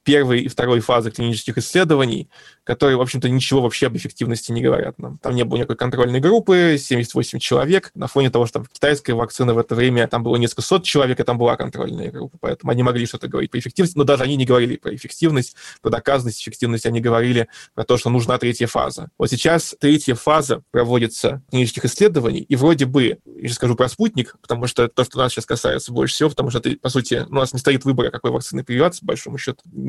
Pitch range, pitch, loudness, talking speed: 120-140 Hz, 125 Hz, -19 LUFS, 215 wpm